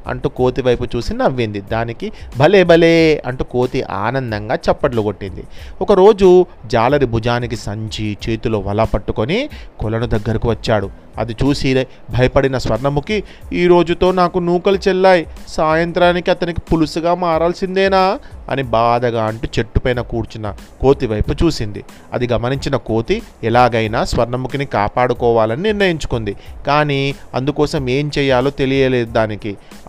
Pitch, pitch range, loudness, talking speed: 125 Hz, 115-160 Hz, -16 LUFS, 110 wpm